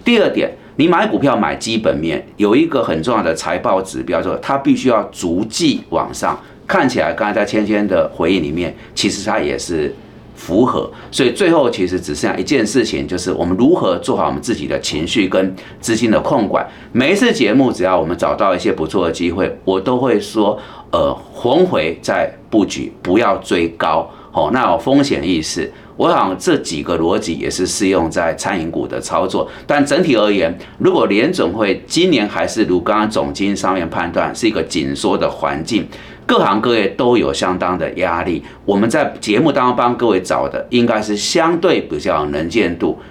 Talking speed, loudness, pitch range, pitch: 285 characters per minute, -16 LUFS, 95-120 Hz, 105 Hz